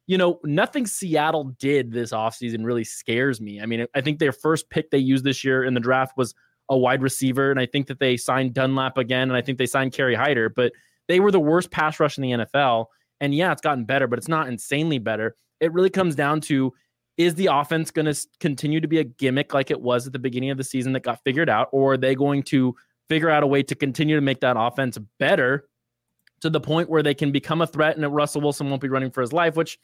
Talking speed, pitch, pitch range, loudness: 255 wpm, 135 Hz, 125-155 Hz, -22 LUFS